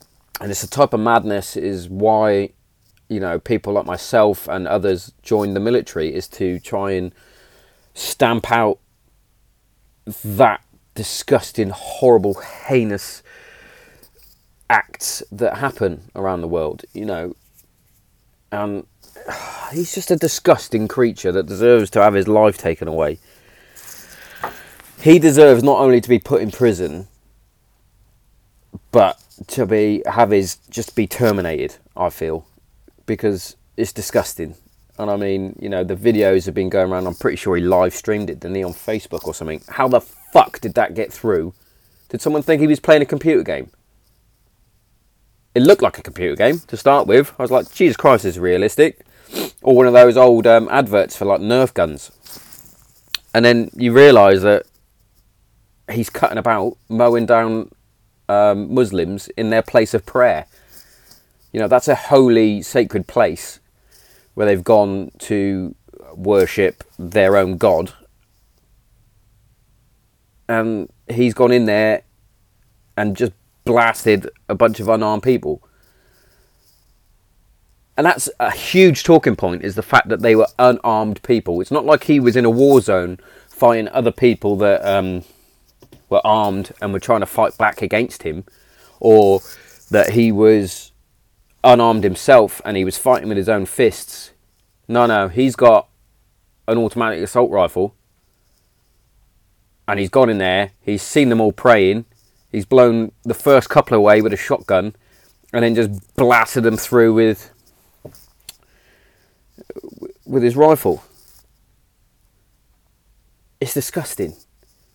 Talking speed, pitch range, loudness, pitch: 145 wpm, 100-120 Hz, -16 LUFS, 110 Hz